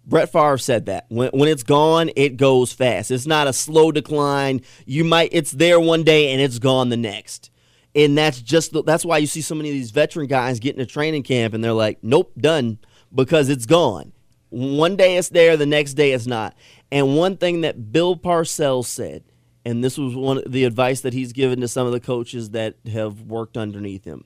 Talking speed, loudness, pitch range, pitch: 220 wpm, -18 LUFS, 120-155 Hz, 135 Hz